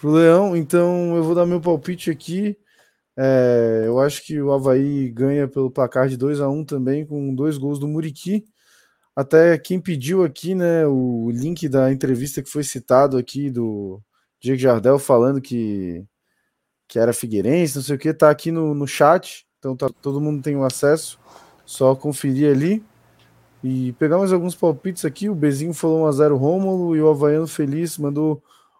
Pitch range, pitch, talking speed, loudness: 130-165 Hz, 145 Hz, 175 wpm, -19 LUFS